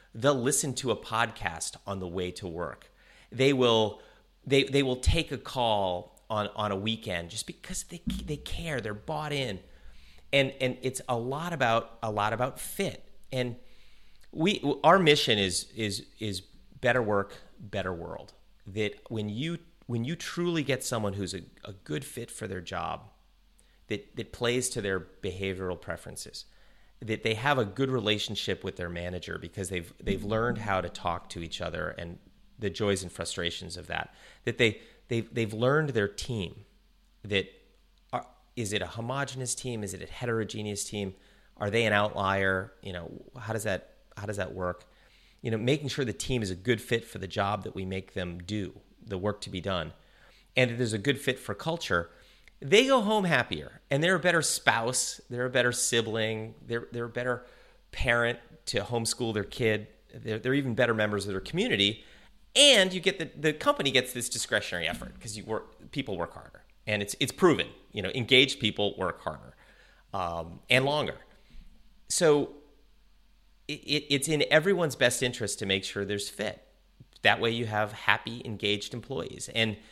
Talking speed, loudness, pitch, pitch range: 185 wpm, -29 LUFS, 110 Hz, 100-130 Hz